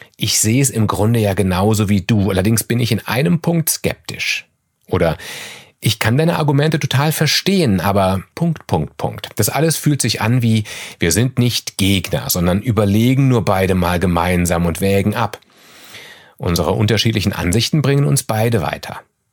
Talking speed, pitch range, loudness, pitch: 165 wpm, 100-135 Hz, -16 LUFS, 110 Hz